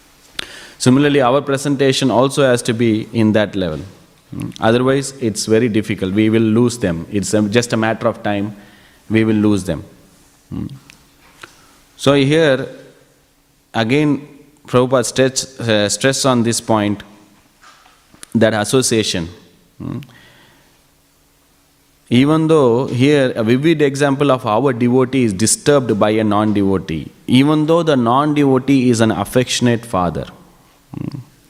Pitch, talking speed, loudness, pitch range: 120 Hz, 115 wpm, -15 LUFS, 105-135 Hz